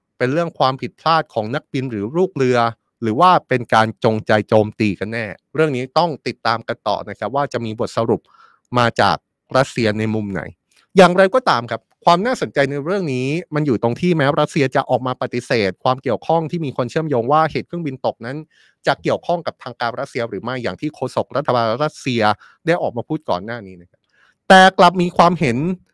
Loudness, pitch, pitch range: -18 LUFS, 130 Hz, 115-160 Hz